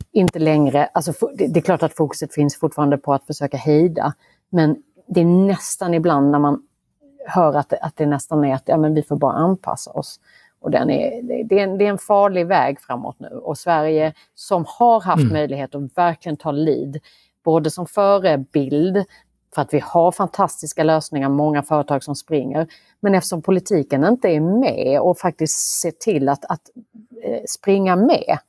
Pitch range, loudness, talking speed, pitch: 150-190 Hz, -19 LUFS, 175 wpm, 160 Hz